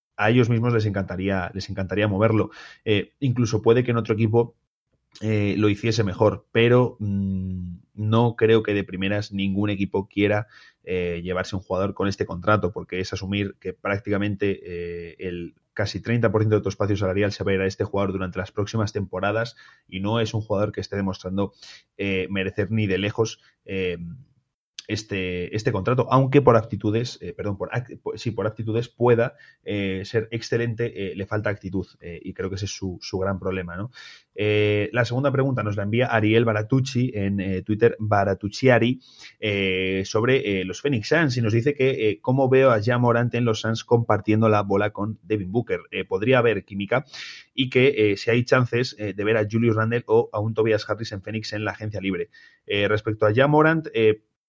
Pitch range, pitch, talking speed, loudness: 100-115 Hz, 105 Hz, 195 wpm, -23 LUFS